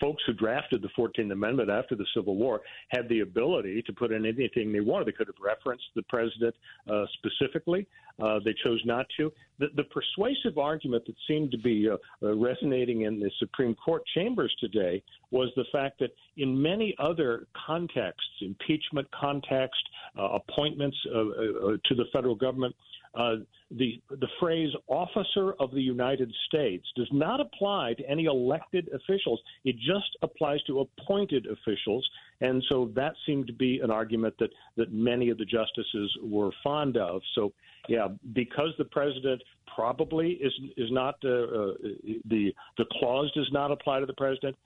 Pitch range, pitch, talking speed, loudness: 115-150 Hz, 130 Hz, 170 wpm, -30 LUFS